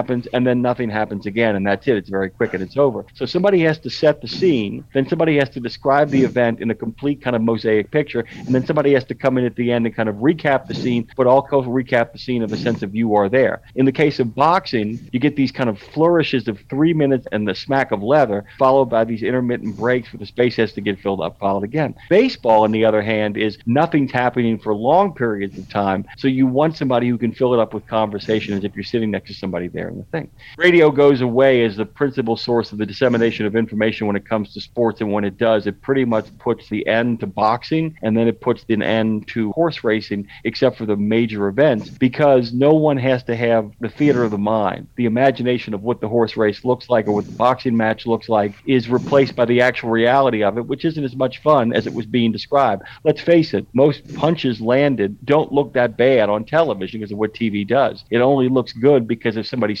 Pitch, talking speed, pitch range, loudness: 120 Hz, 245 wpm, 110-135 Hz, -18 LUFS